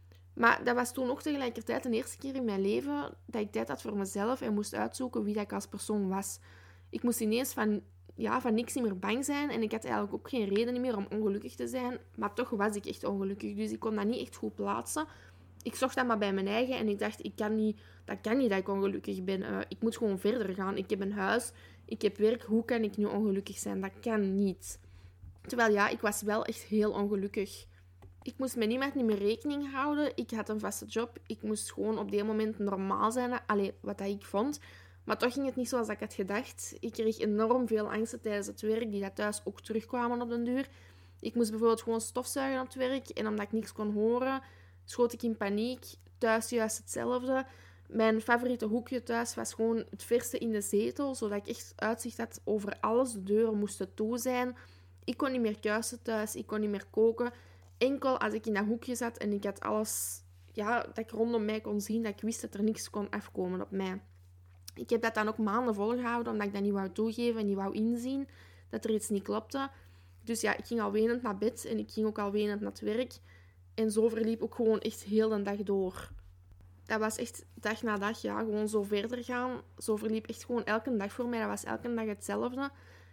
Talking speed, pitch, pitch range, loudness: 230 wpm, 215 Hz, 200-235 Hz, -33 LUFS